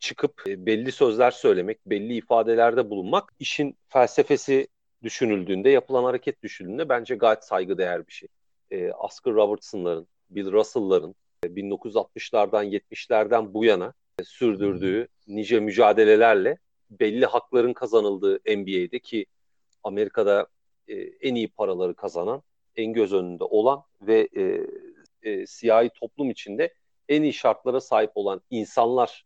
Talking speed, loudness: 110 wpm, -24 LUFS